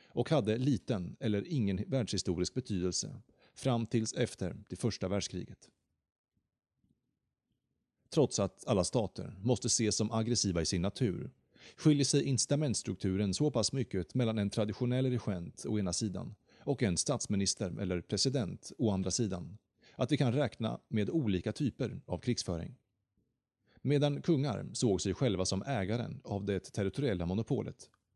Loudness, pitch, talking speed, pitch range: -34 LUFS, 110 Hz, 140 wpm, 95-130 Hz